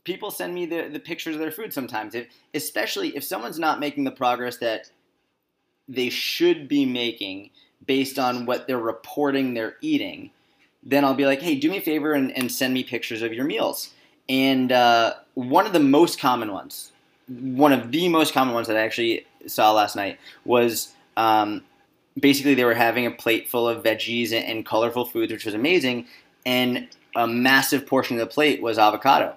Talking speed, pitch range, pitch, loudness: 190 wpm, 115-150 Hz, 130 Hz, -22 LUFS